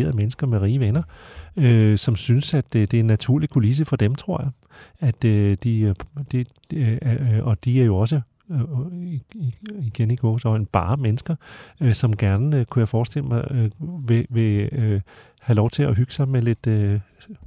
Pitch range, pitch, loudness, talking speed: 110-135 Hz, 120 Hz, -21 LUFS, 145 wpm